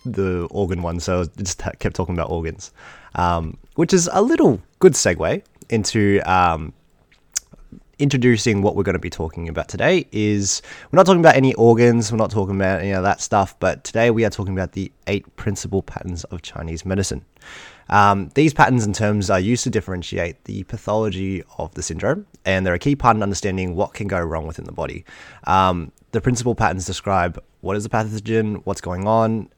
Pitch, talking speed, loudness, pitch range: 100 Hz, 195 wpm, -19 LUFS, 90-115 Hz